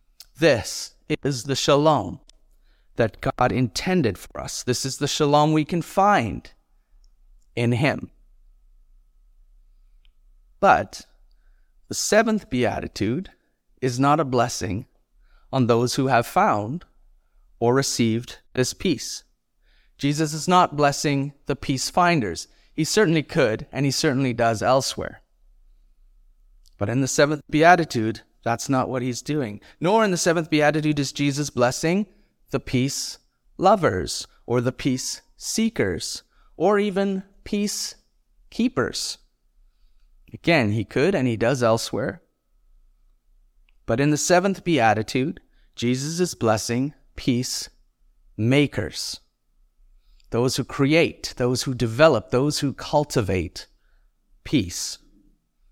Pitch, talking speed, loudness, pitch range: 130 Hz, 115 wpm, -22 LUFS, 95-150 Hz